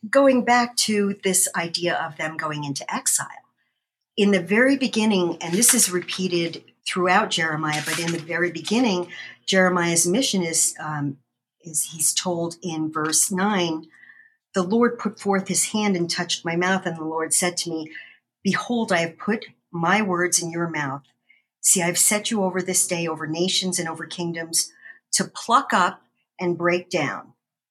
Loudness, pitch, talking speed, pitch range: -22 LUFS, 180 Hz, 170 wpm, 165-205 Hz